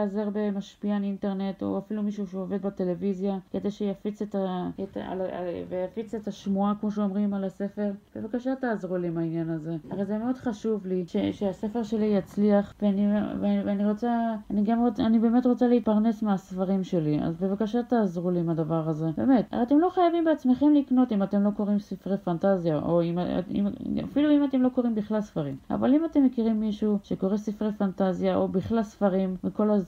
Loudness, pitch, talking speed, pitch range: -27 LUFS, 205 Hz, 160 wpm, 190-225 Hz